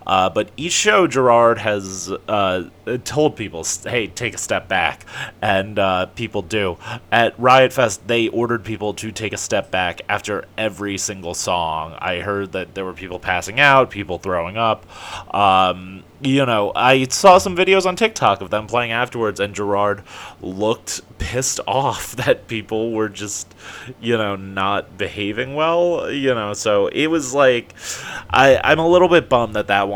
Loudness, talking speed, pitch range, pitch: -18 LUFS, 170 wpm, 100-130 Hz, 110 Hz